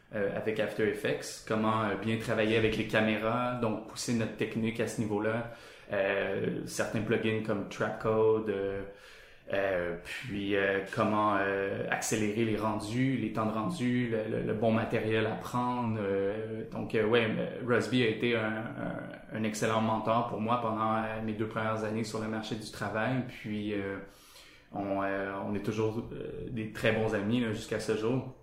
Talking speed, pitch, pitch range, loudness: 175 wpm, 110 Hz, 105-115 Hz, -32 LUFS